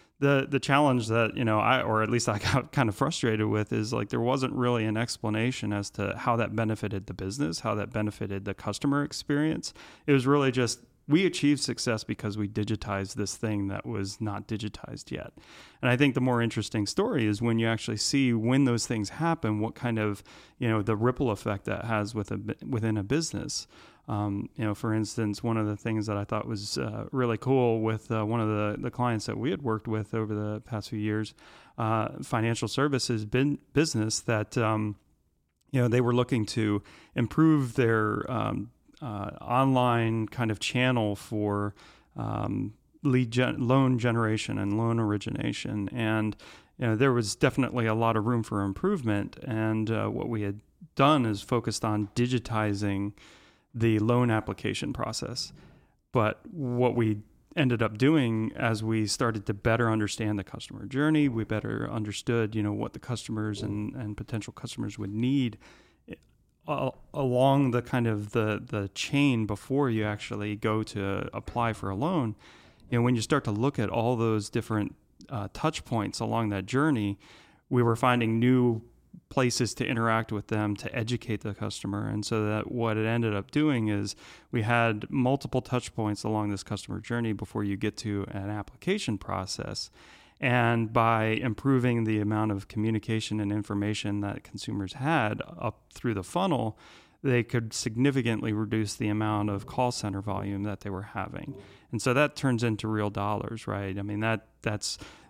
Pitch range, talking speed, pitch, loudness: 105-125 Hz, 180 wpm, 110 Hz, -29 LUFS